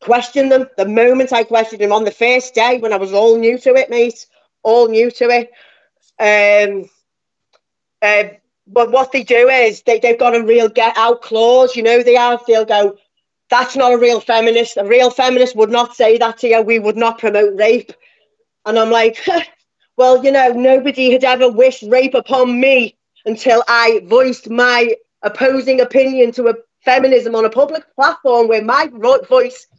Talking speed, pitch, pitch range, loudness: 185 wpm, 240 Hz, 225-255 Hz, -12 LUFS